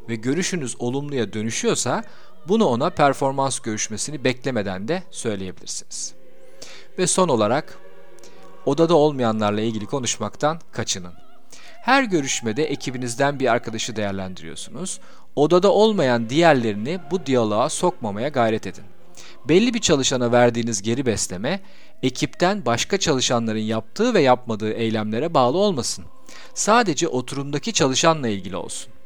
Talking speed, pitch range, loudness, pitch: 110 wpm, 115-170 Hz, -21 LUFS, 130 Hz